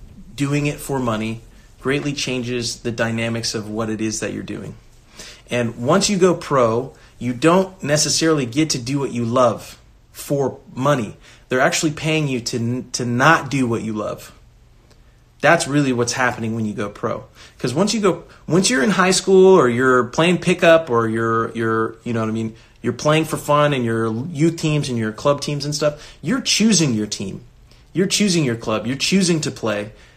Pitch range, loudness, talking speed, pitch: 115-160 Hz, -19 LUFS, 195 wpm, 130 Hz